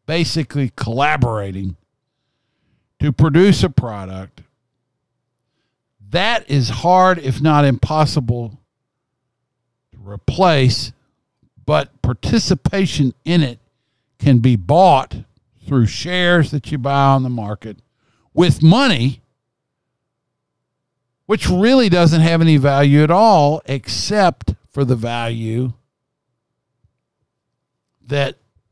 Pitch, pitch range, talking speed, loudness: 135 Hz, 120-150 Hz, 90 wpm, -15 LUFS